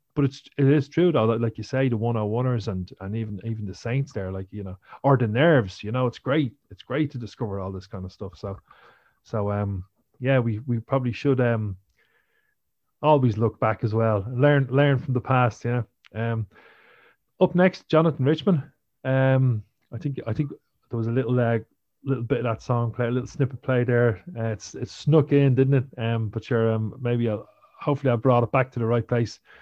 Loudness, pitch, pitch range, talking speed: -24 LUFS, 120 Hz, 110-135 Hz, 220 wpm